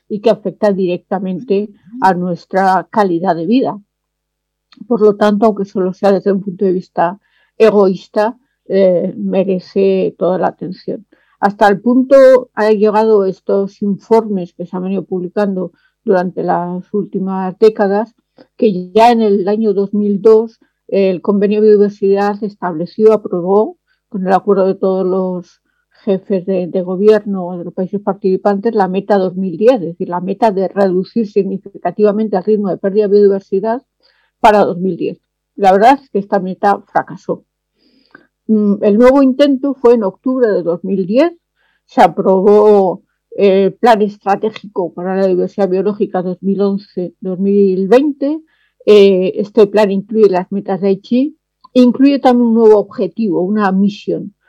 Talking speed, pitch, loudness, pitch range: 140 wpm, 200 Hz, -13 LUFS, 190-220 Hz